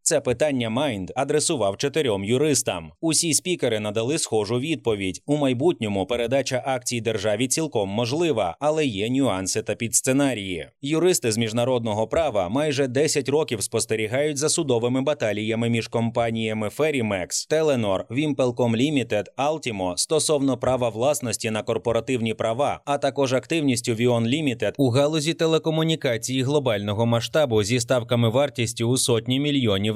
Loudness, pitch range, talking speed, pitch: -23 LUFS, 115-145 Hz, 125 wpm, 125 Hz